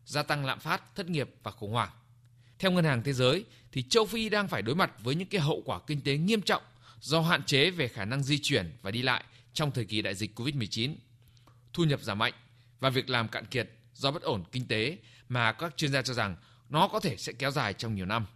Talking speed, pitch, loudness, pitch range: 250 wpm, 125 Hz, -30 LUFS, 115-150 Hz